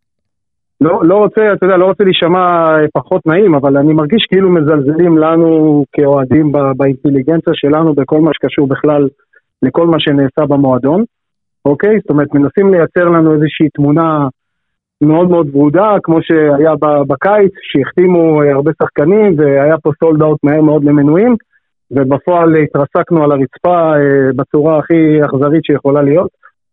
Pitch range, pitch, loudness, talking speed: 145-170 Hz, 155 Hz, -10 LUFS, 135 wpm